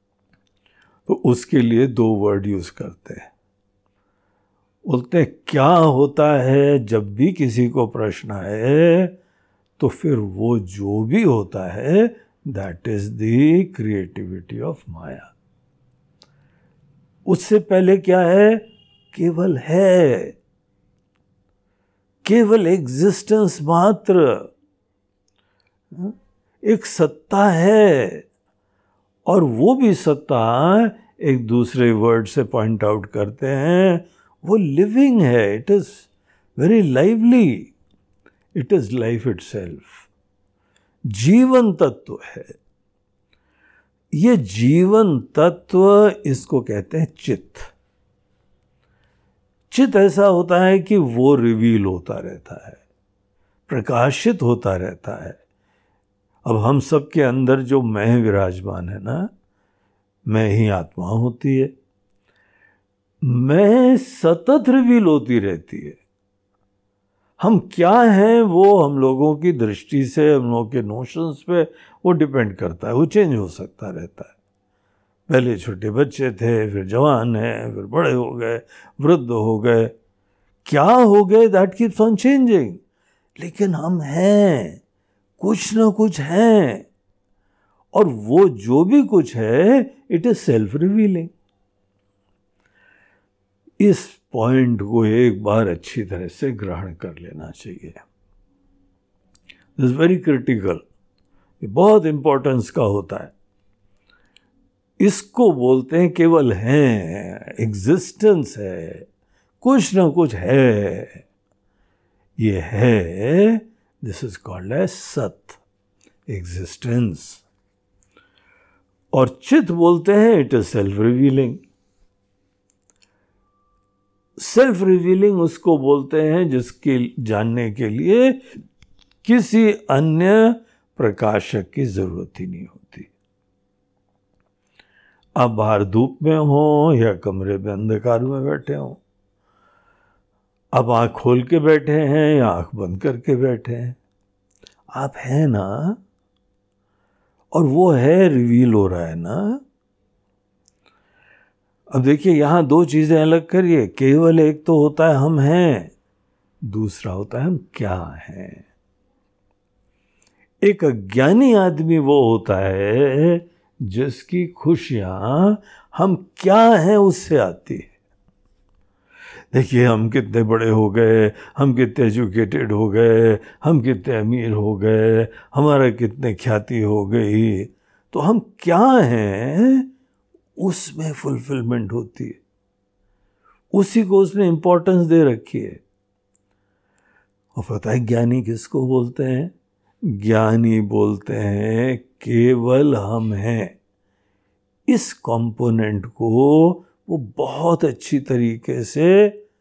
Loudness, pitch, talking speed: -17 LUFS, 125 Hz, 110 wpm